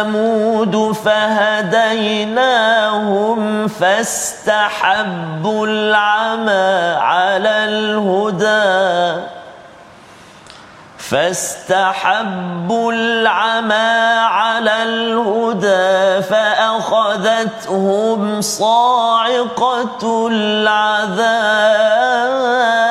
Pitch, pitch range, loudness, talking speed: 215 Hz, 210-225 Hz, -14 LUFS, 30 wpm